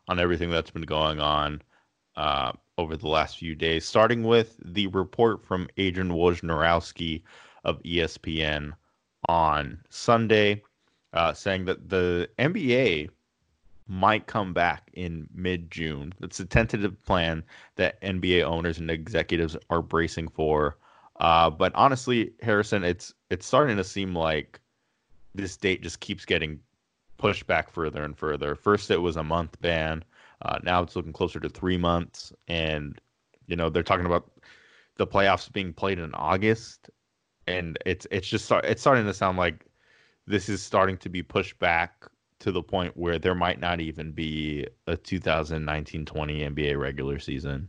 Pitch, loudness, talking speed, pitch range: 85 Hz, -26 LUFS, 155 wpm, 80-95 Hz